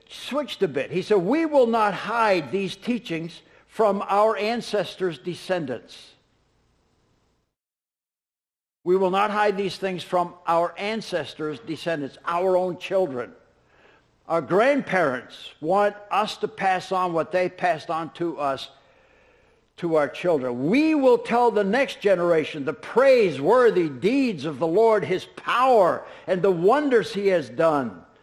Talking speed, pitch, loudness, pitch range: 135 wpm, 185 Hz, -23 LUFS, 165-225 Hz